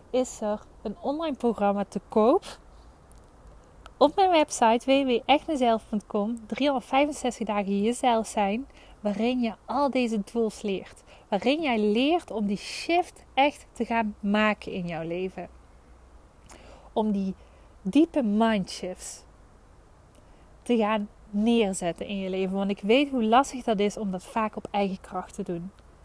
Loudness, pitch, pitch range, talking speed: -26 LUFS, 215 Hz, 195-245 Hz, 135 wpm